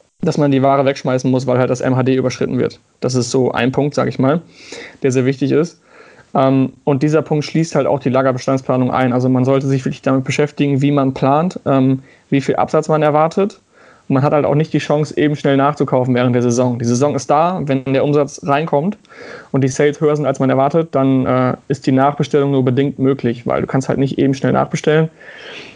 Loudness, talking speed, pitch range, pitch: -16 LUFS, 215 wpm, 130-150 Hz, 140 Hz